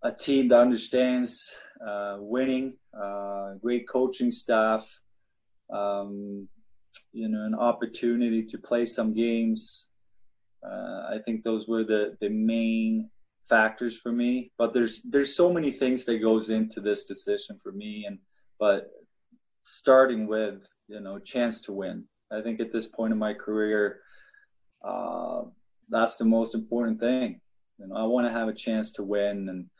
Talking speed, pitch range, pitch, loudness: 155 wpm, 110-125 Hz, 115 Hz, -27 LUFS